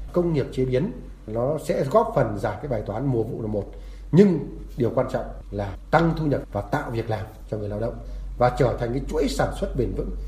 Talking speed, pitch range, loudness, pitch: 240 wpm, 110-145 Hz, -24 LUFS, 120 Hz